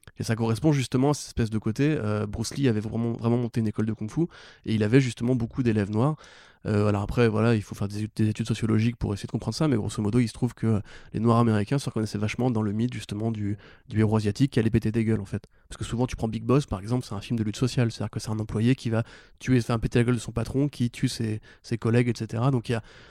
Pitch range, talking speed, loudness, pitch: 110-125 Hz, 295 wpm, -26 LUFS, 115 Hz